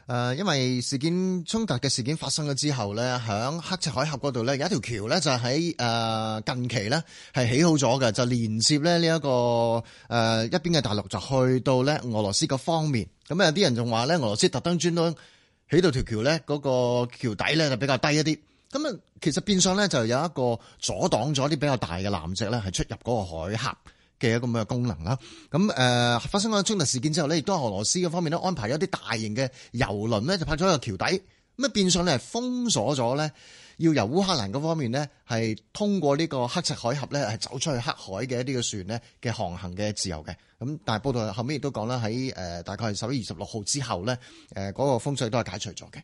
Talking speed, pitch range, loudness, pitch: 335 characters per minute, 115-160 Hz, -26 LUFS, 130 Hz